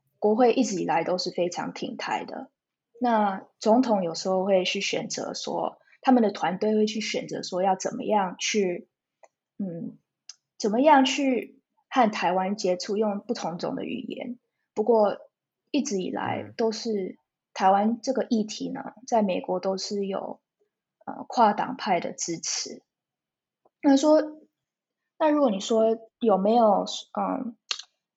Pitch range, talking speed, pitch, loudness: 195-245 Hz, 200 characters per minute, 215 Hz, -25 LUFS